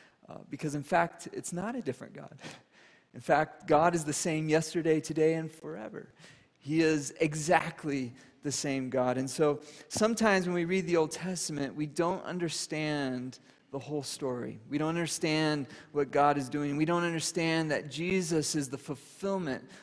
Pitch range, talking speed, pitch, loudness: 145-170 Hz, 165 wpm, 155 Hz, -31 LUFS